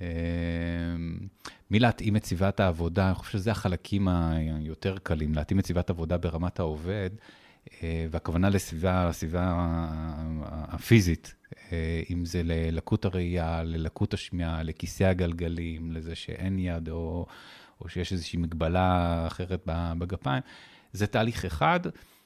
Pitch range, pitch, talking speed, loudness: 80-95 Hz, 85 Hz, 110 wpm, -29 LUFS